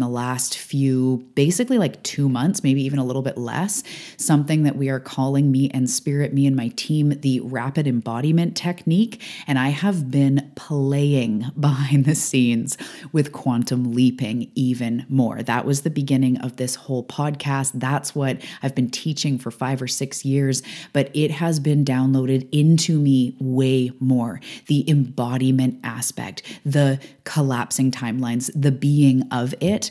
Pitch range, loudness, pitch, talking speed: 130-145 Hz, -21 LUFS, 135 Hz, 160 wpm